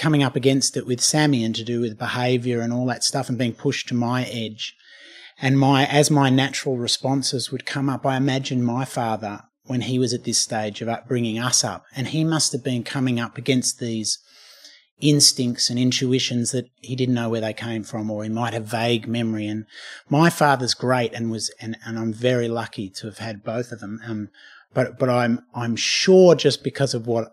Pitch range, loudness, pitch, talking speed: 115-135 Hz, -21 LUFS, 125 Hz, 215 wpm